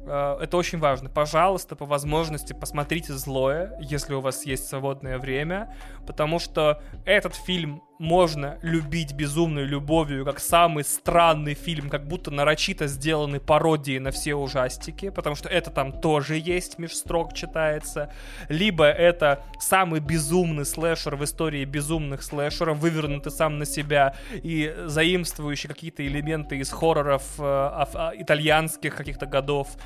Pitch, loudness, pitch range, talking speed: 150 Hz, -25 LUFS, 145-165 Hz, 135 wpm